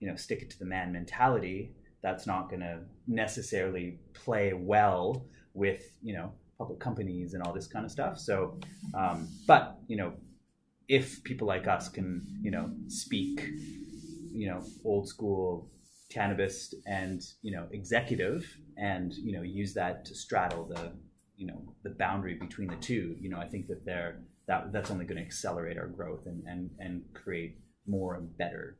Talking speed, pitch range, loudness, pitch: 175 wpm, 90-105 Hz, -34 LUFS, 95 Hz